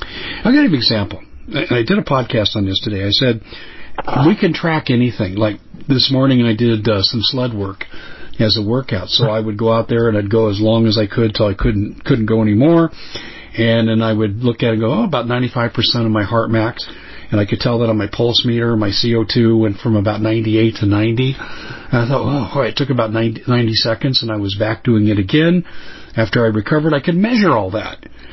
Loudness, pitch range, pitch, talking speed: -15 LUFS, 110-125 Hz, 115 Hz, 235 wpm